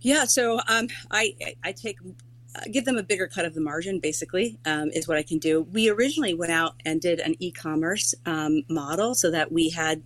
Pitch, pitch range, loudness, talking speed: 165 Hz, 155-205 Hz, -25 LUFS, 215 wpm